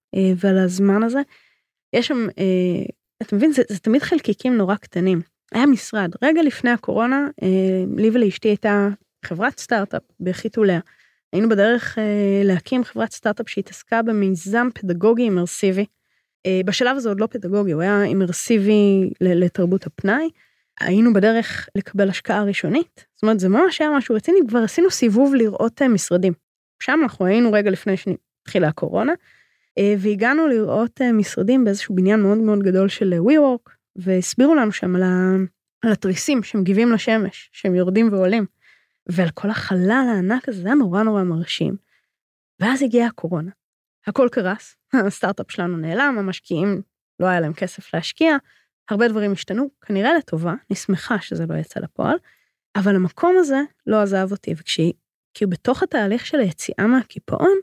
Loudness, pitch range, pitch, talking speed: -19 LUFS, 190-240 Hz, 205 Hz, 145 wpm